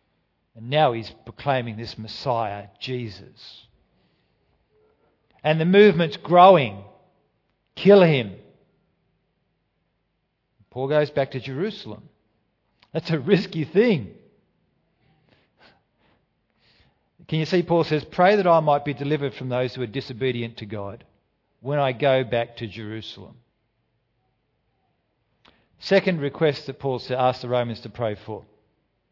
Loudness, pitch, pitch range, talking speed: -22 LUFS, 130 Hz, 115-155 Hz, 115 wpm